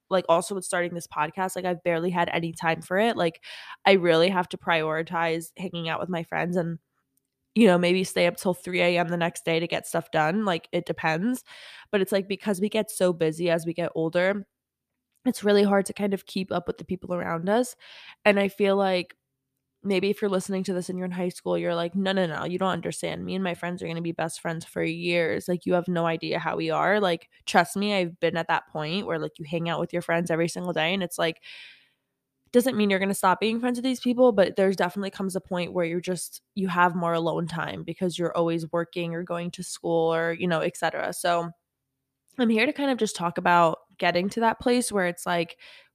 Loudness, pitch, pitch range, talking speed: -26 LUFS, 175 Hz, 165-195 Hz, 245 wpm